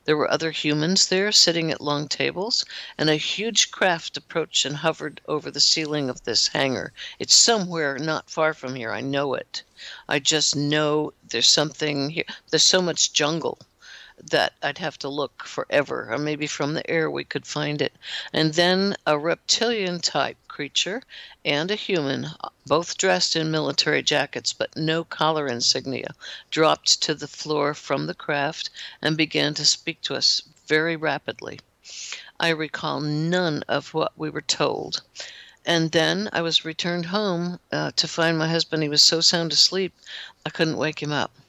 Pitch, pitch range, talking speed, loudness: 155 Hz, 150-170 Hz, 170 wpm, -22 LUFS